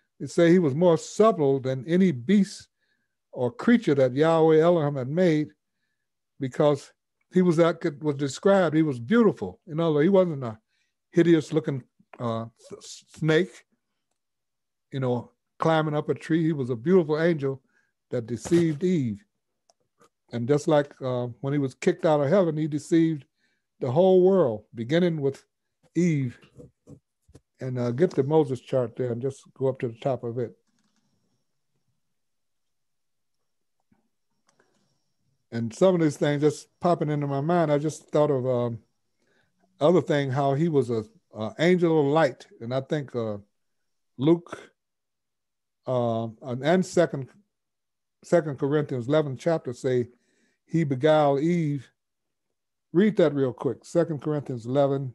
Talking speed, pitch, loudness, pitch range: 145 wpm, 150 Hz, -24 LUFS, 130-170 Hz